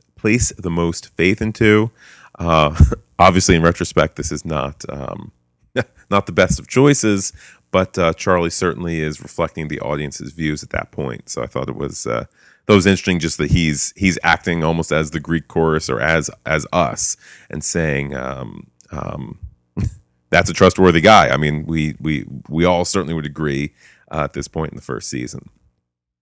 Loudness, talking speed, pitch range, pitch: -17 LUFS, 180 wpm, 75-95 Hz, 80 Hz